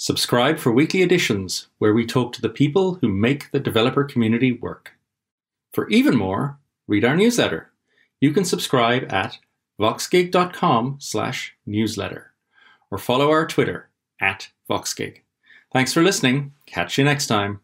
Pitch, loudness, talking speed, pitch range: 130 Hz, -20 LUFS, 135 wpm, 115-145 Hz